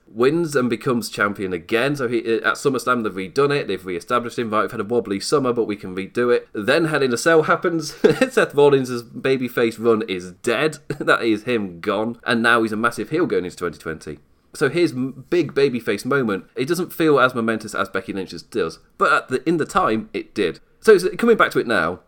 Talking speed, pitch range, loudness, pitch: 215 wpm, 110-145 Hz, -20 LUFS, 120 Hz